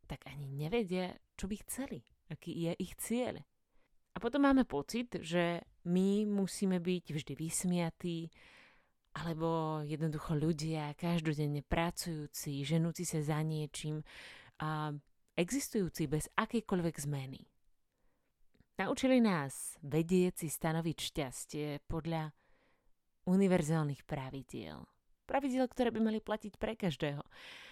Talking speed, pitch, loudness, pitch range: 110 wpm, 165 Hz, -36 LUFS, 150-190 Hz